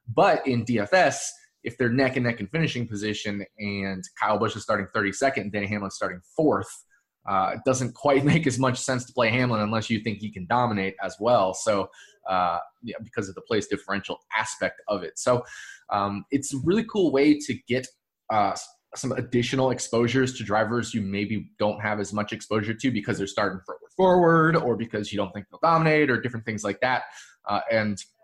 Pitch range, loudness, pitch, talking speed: 105-135 Hz, -25 LUFS, 120 Hz, 195 wpm